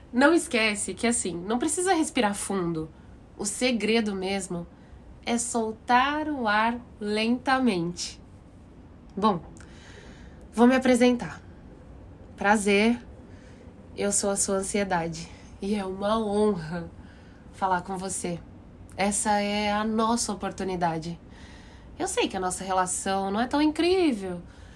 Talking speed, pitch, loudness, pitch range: 115 wpm, 200 Hz, -26 LUFS, 175-235 Hz